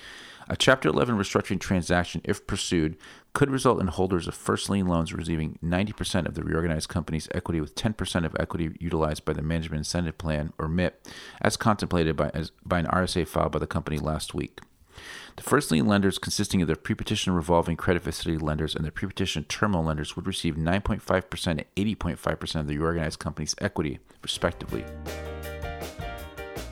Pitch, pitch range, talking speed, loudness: 85 Hz, 80-95 Hz, 170 wpm, -27 LUFS